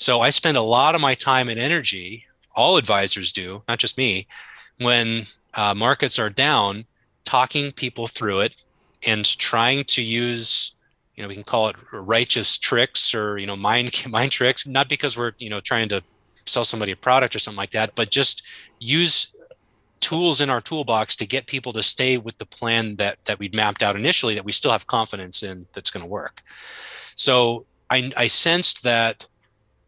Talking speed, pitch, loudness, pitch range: 185 wpm, 115 Hz, -19 LUFS, 105-130 Hz